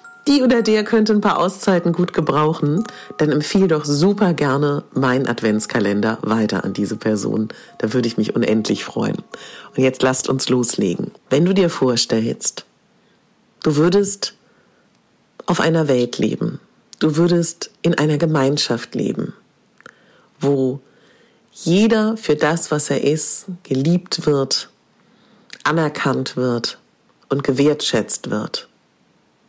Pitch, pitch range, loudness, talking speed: 150 Hz, 130-175 Hz, -18 LUFS, 125 wpm